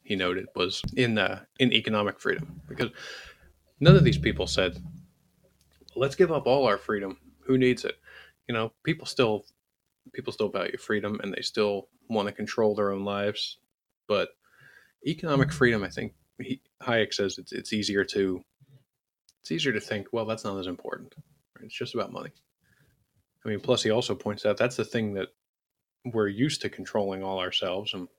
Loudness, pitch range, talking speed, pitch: -27 LUFS, 100-125 Hz, 180 wpm, 105 Hz